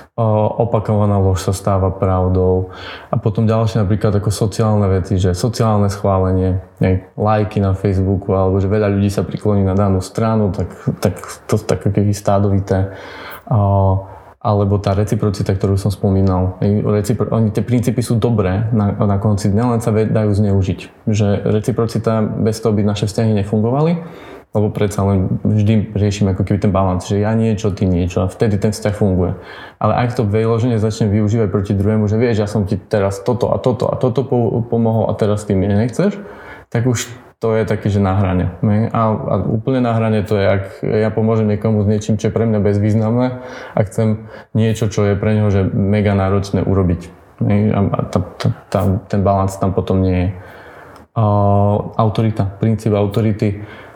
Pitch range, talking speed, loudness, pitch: 100-110 Hz, 170 wpm, -16 LUFS, 105 Hz